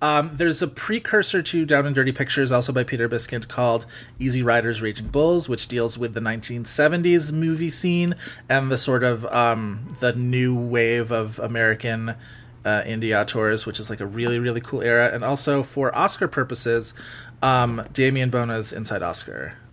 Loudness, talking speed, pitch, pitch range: -22 LUFS, 170 wpm, 120 Hz, 115-140 Hz